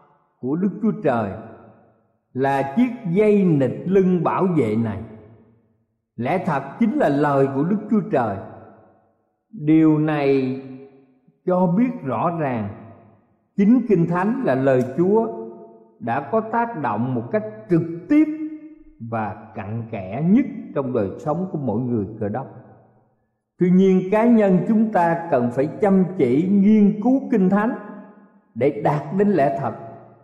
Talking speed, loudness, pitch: 145 wpm, -20 LUFS, 145 Hz